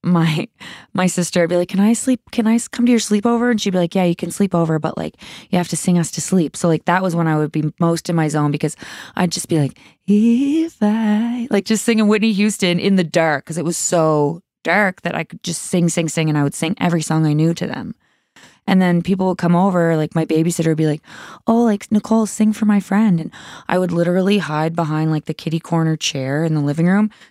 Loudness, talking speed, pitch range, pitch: -17 LUFS, 255 wpm, 165-205 Hz, 175 Hz